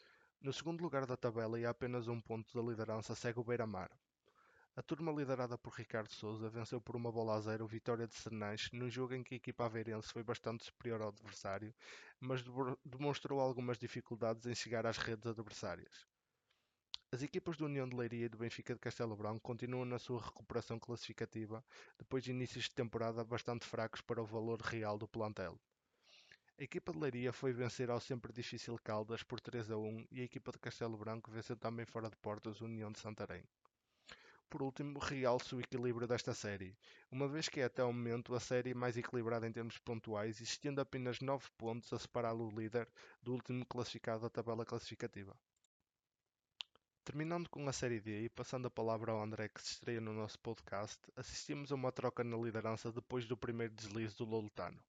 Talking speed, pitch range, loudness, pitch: 190 wpm, 110-125 Hz, -44 LUFS, 120 Hz